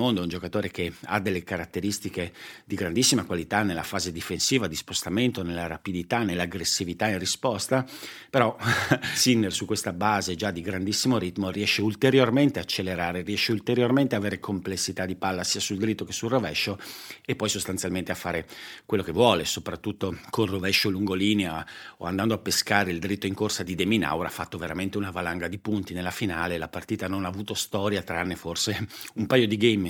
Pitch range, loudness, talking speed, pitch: 90-105 Hz, -26 LUFS, 180 wpm, 100 Hz